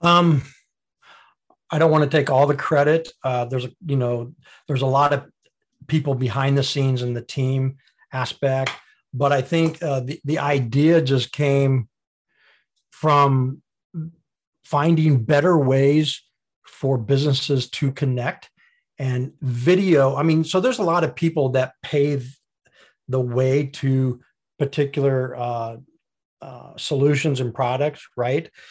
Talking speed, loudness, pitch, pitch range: 135 wpm, -21 LUFS, 140 Hz, 130-155 Hz